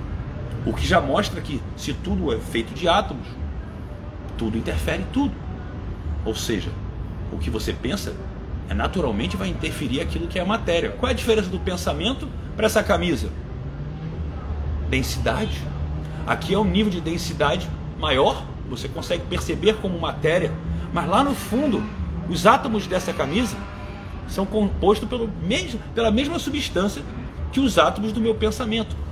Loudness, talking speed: -24 LUFS, 145 wpm